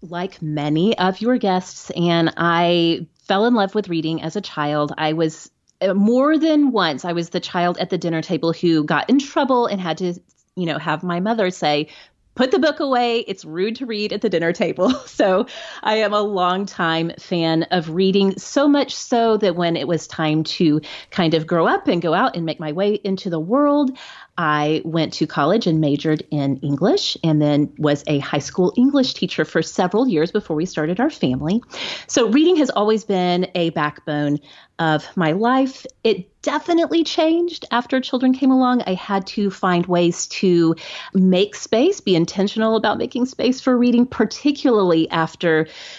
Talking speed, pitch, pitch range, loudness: 185 wpm, 185 Hz, 165-230 Hz, -19 LUFS